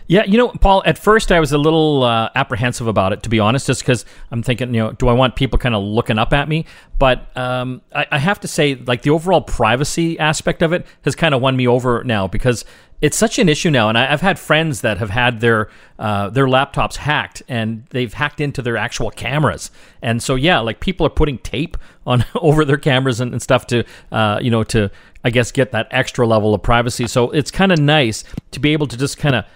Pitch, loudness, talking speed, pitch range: 125 Hz, -16 LUFS, 245 wpm, 115-150 Hz